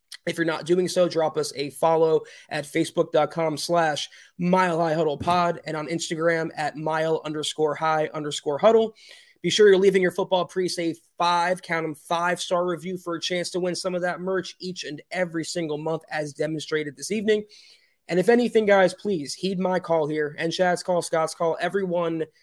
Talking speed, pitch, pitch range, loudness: 190 wpm, 170 Hz, 155-185 Hz, -24 LUFS